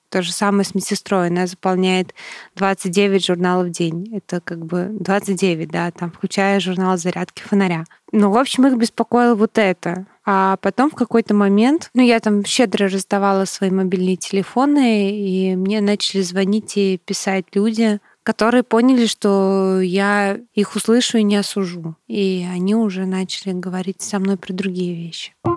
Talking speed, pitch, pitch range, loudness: 155 wpm, 195 Hz, 185-210 Hz, -18 LUFS